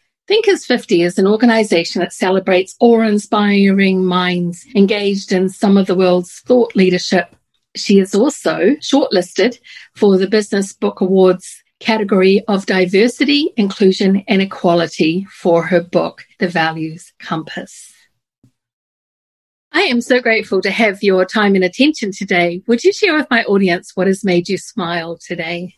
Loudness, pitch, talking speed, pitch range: -14 LUFS, 195 Hz, 140 wpm, 180-220 Hz